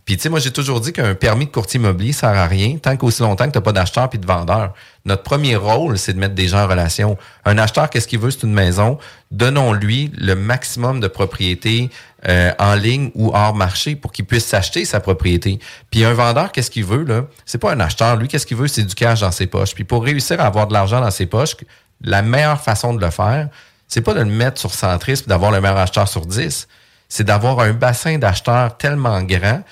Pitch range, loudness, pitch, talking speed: 100-125 Hz, -16 LUFS, 115 Hz, 240 wpm